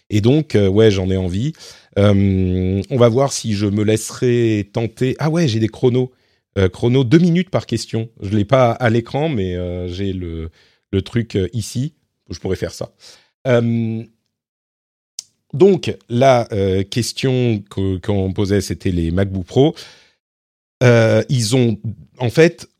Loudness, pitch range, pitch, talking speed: -17 LUFS, 95-125 Hz, 110 Hz, 160 wpm